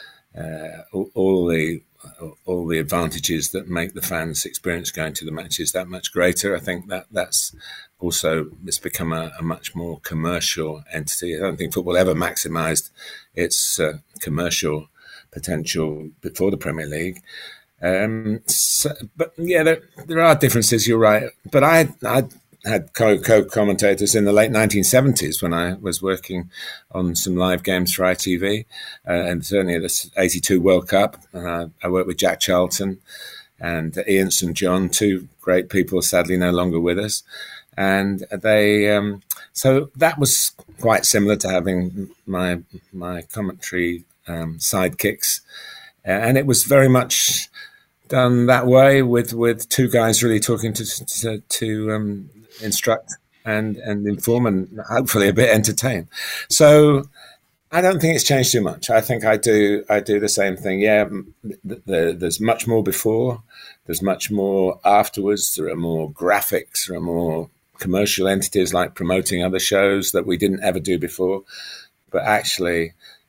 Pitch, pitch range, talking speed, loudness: 100 Hz, 90-115 Hz, 160 wpm, -19 LUFS